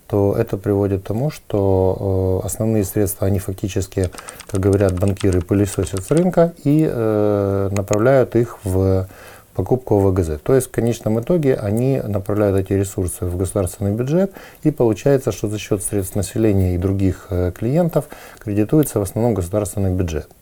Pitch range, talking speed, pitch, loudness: 95-115 Hz, 155 wpm, 100 Hz, -19 LUFS